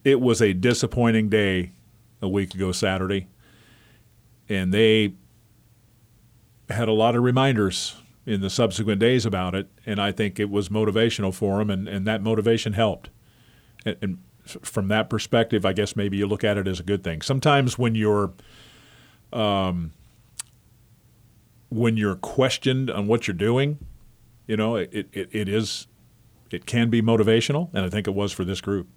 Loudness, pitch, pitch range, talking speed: -23 LUFS, 110 Hz, 100-115 Hz, 165 wpm